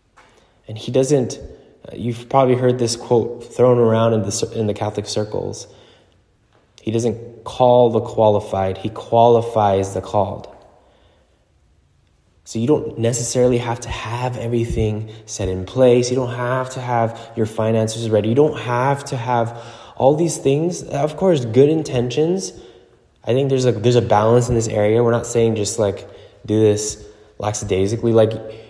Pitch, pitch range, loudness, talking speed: 115 Hz, 110-125 Hz, -18 LUFS, 155 wpm